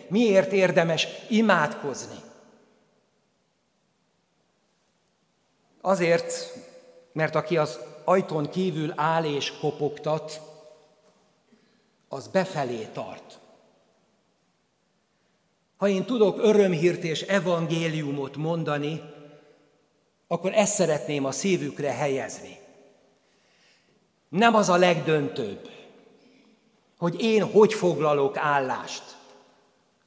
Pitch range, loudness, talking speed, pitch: 155-210 Hz, -24 LUFS, 75 wpm, 175 Hz